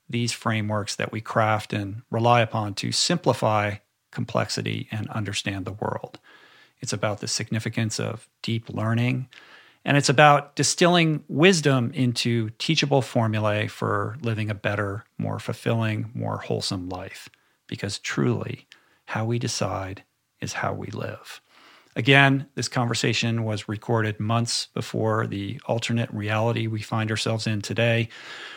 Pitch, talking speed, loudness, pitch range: 115 Hz, 130 wpm, -24 LUFS, 105-125 Hz